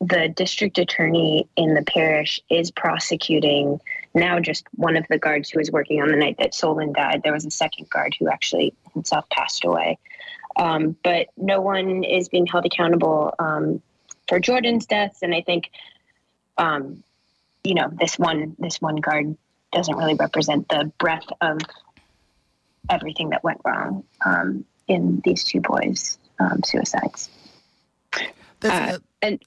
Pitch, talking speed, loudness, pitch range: 165 Hz, 155 wpm, -21 LUFS, 155-180 Hz